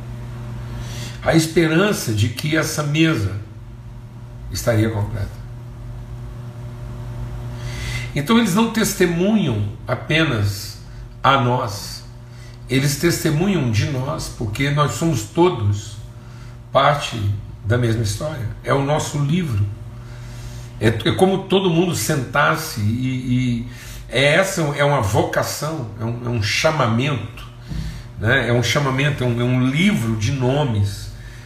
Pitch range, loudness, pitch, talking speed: 115-150 Hz, -19 LUFS, 120 Hz, 115 wpm